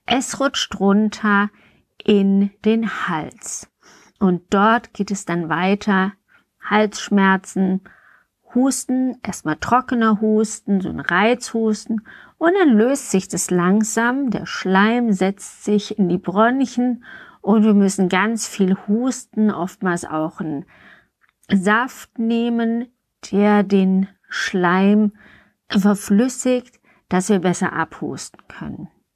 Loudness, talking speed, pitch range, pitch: -19 LUFS, 110 wpm, 190-235 Hz, 210 Hz